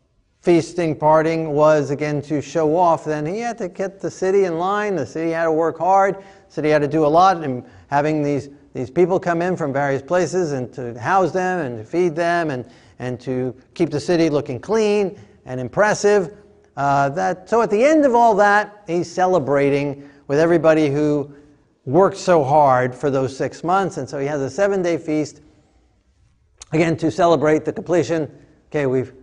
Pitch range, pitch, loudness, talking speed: 140-180 Hz, 155 Hz, -19 LUFS, 190 wpm